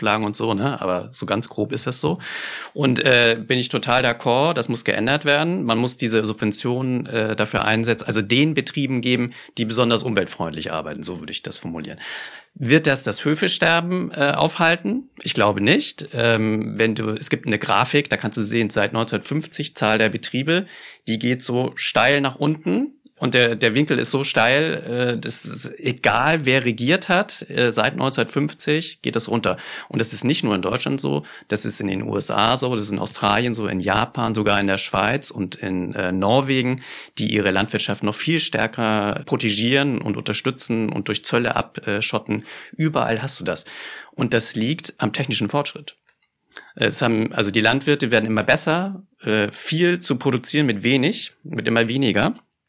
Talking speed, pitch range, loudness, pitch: 180 wpm, 110-140 Hz, -20 LUFS, 120 Hz